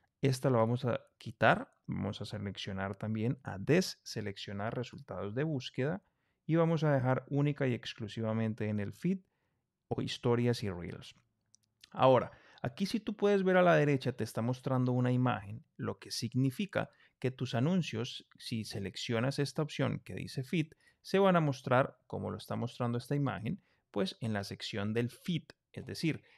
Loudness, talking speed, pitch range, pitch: -34 LUFS, 165 wpm, 110-145 Hz, 125 Hz